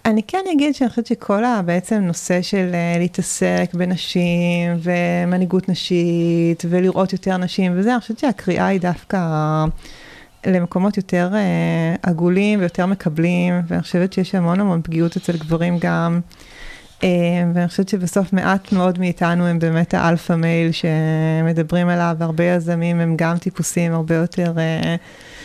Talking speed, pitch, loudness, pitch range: 140 wpm, 175 Hz, -18 LUFS, 170-190 Hz